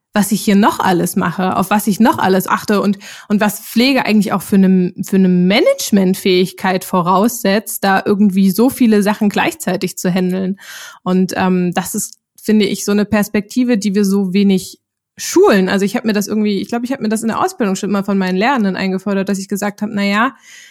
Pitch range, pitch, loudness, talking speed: 190-215 Hz, 205 Hz, -14 LUFS, 210 wpm